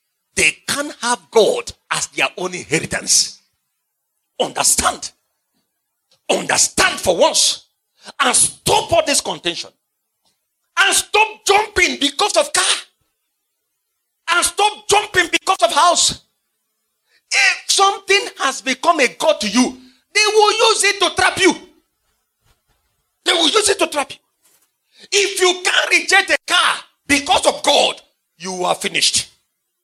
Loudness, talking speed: -15 LUFS, 125 wpm